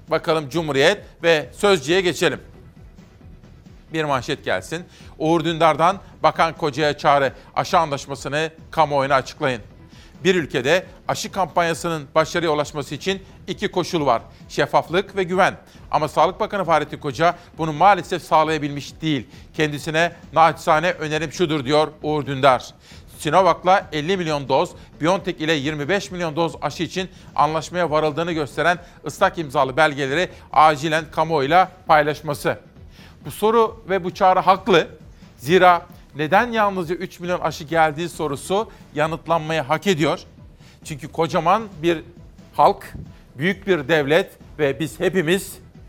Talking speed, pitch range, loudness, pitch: 120 wpm, 150-180 Hz, -20 LUFS, 165 Hz